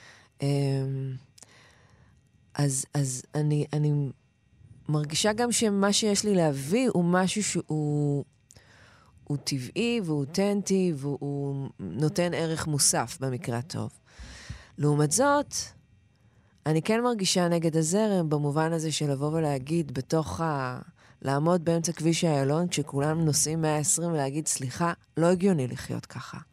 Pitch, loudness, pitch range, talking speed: 150 Hz, -27 LUFS, 135-170 Hz, 115 wpm